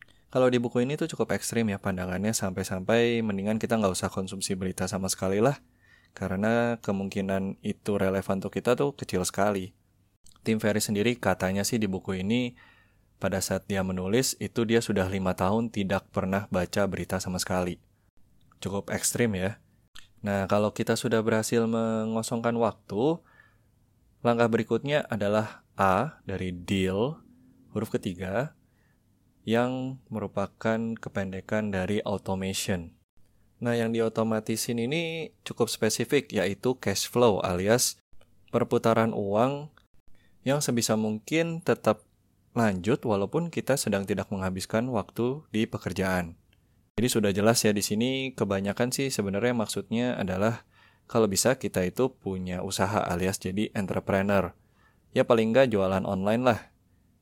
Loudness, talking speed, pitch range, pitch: -28 LUFS, 130 wpm, 95-115 Hz, 105 Hz